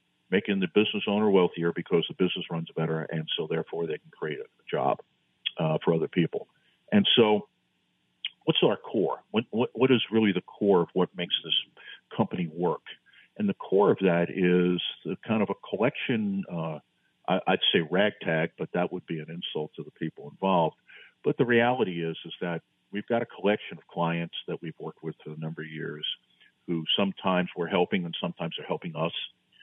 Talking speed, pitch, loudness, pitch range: 195 wpm, 90 Hz, -28 LUFS, 80-110 Hz